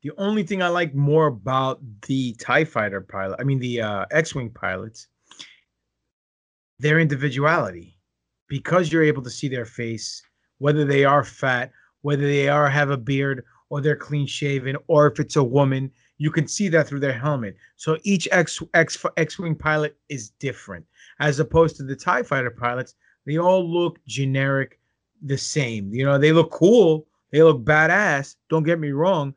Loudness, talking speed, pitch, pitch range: -21 LUFS, 170 wpm, 140 Hz, 125-155 Hz